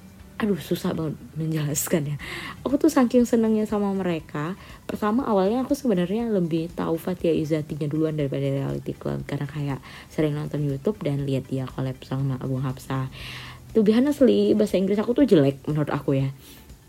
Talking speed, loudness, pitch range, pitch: 165 wpm, -24 LUFS, 140-210 Hz, 160 Hz